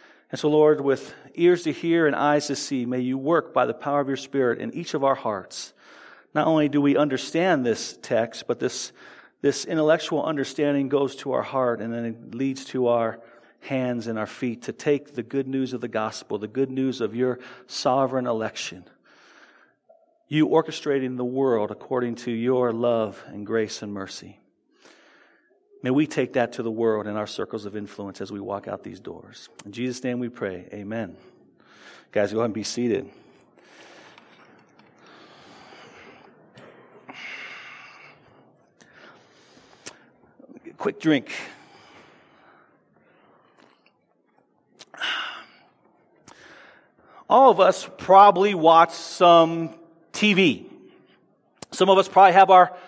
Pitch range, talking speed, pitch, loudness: 120-165 Hz, 140 wpm, 135 Hz, -23 LUFS